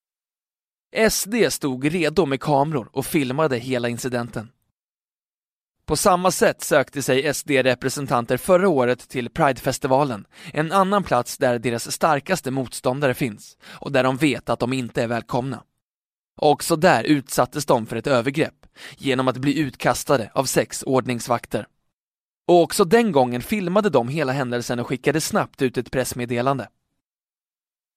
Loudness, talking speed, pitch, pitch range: -21 LUFS, 135 wpm, 135 Hz, 125-155 Hz